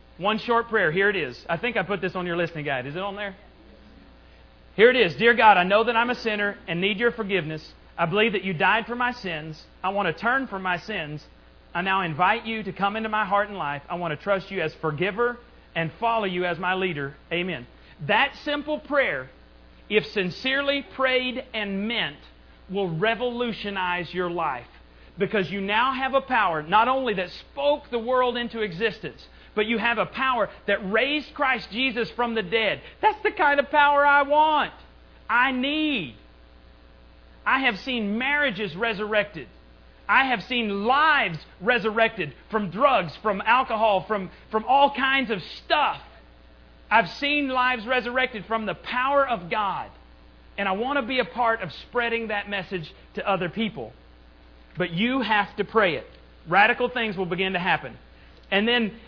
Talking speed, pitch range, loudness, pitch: 180 wpm, 170-245 Hz, -24 LUFS, 205 Hz